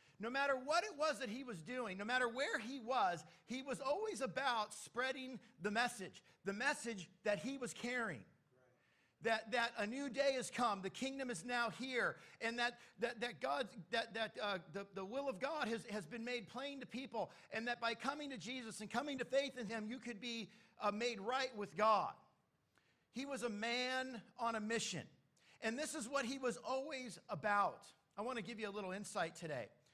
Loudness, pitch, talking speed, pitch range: -42 LUFS, 240 Hz, 205 wpm, 210-260 Hz